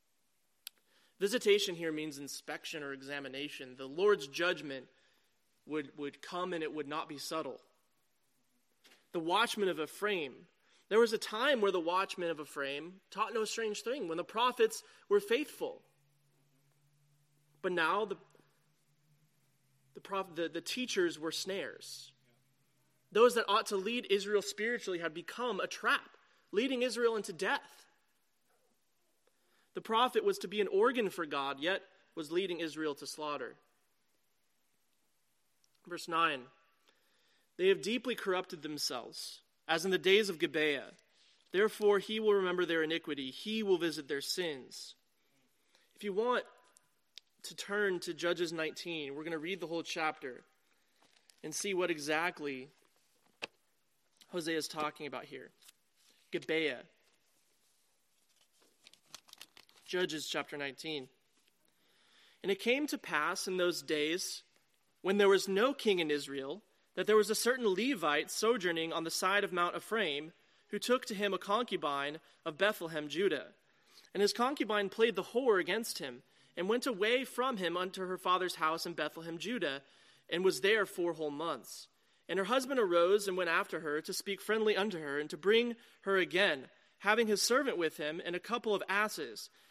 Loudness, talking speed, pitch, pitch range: -34 LUFS, 150 wpm, 180 Hz, 155-210 Hz